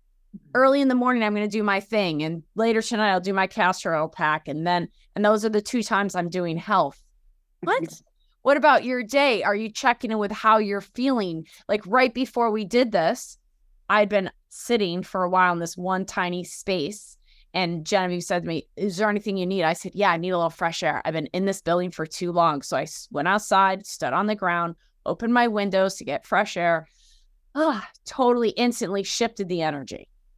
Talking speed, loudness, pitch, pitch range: 215 wpm, -23 LUFS, 195 Hz, 175-220 Hz